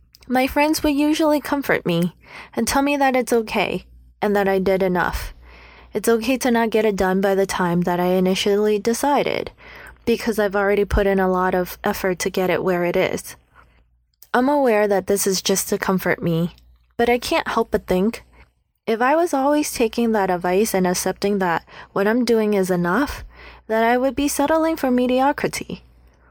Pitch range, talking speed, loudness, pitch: 185-255 Hz, 190 wpm, -20 LUFS, 205 Hz